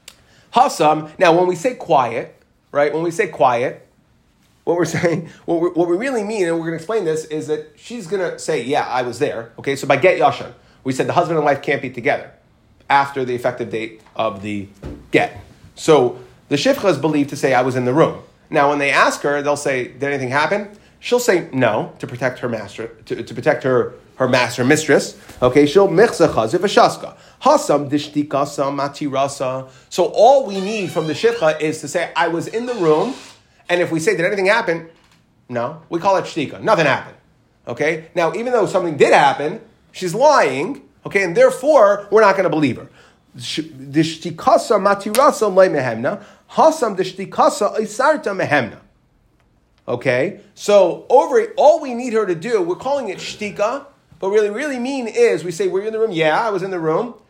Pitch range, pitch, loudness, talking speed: 140-210 Hz, 165 Hz, -17 LUFS, 185 wpm